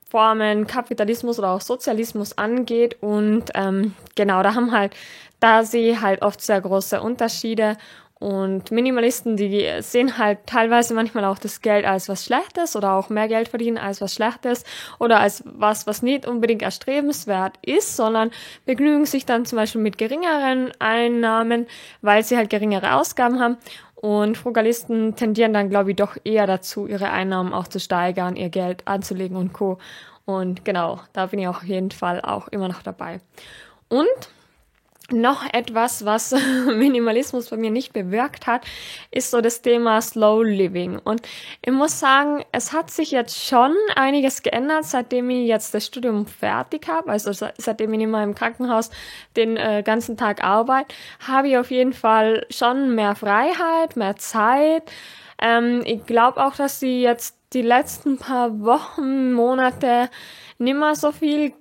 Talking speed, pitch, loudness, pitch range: 160 wpm, 230 Hz, -20 LUFS, 210-250 Hz